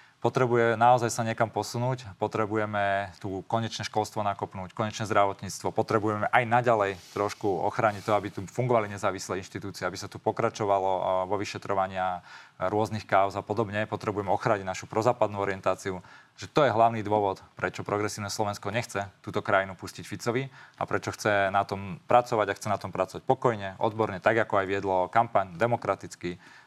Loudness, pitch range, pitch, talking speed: -28 LUFS, 95-115 Hz, 105 Hz, 160 wpm